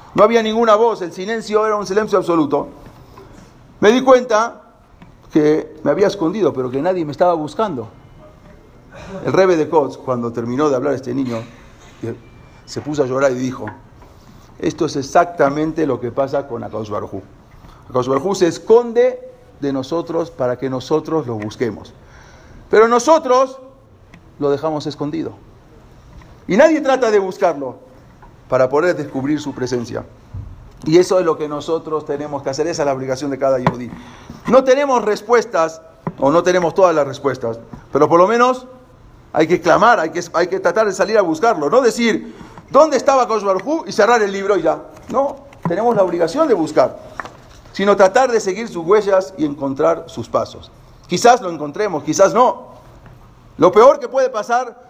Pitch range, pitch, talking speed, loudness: 130-210 Hz, 160 Hz, 165 wpm, -16 LUFS